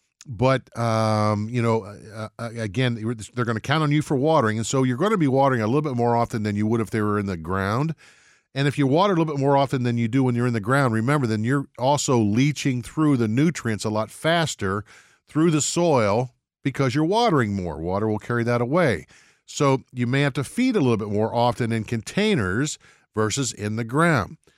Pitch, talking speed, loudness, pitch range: 125 Hz, 220 wpm, -22 LUFS, 110-145 Hz